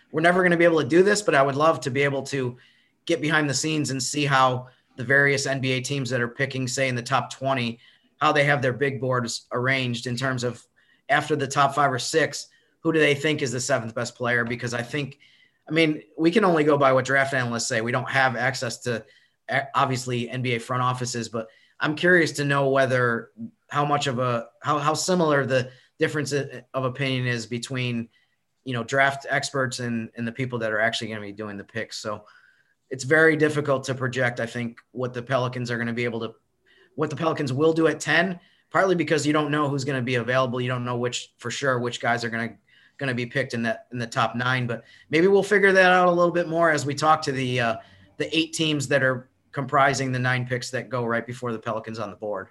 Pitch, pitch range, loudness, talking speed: 130 Hz, 120-150 Hz, -23 LUFS, 240 wpm